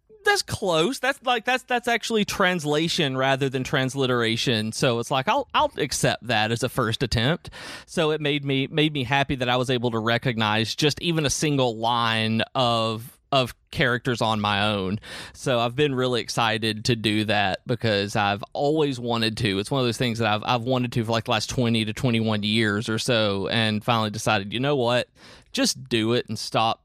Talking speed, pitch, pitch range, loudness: 200 wpm, 125 Hz, 110-140 Hz, -23 LUFS